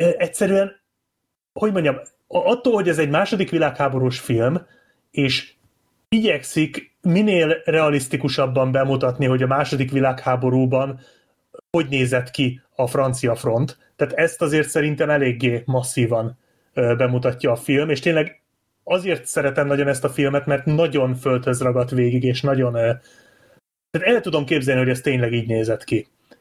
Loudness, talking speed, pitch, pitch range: -20 LUFS, 130 wpm, 140 Hz, 125-160 Hz